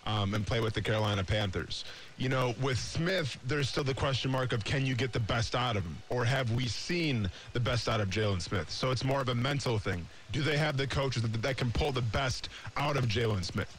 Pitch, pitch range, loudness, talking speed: 120 Hz, 105-135 Hz, -32 LUFS, 250 wpm